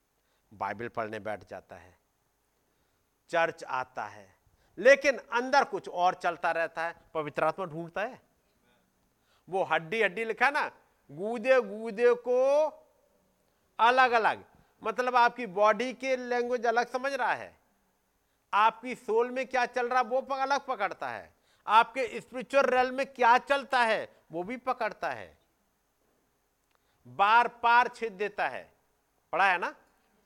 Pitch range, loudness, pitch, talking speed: 185-255 Hz, -28 LUFS, 235 Hz, 135 wpm